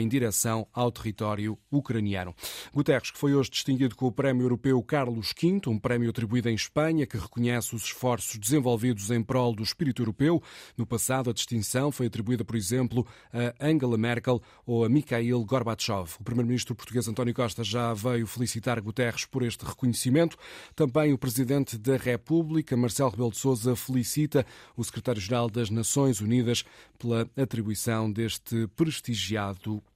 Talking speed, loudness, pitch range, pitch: 155 wpm, -28 LUFS, 115-130 Hz, 120 Hz